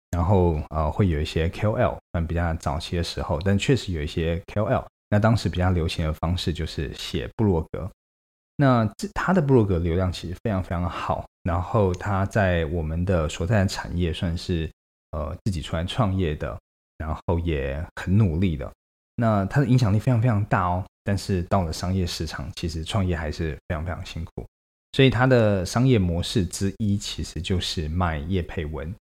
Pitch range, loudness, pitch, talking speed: 80-100 Hz, -24 LUFS, 90 Hz, 285 characters per minute